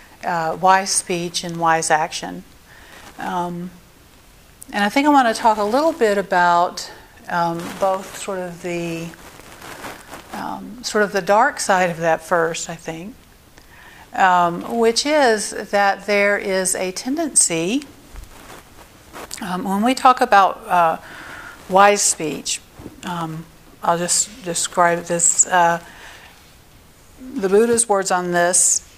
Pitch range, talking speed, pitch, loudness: 170-210 Hz, 125 wpm, 185 Hz, -18 LUFS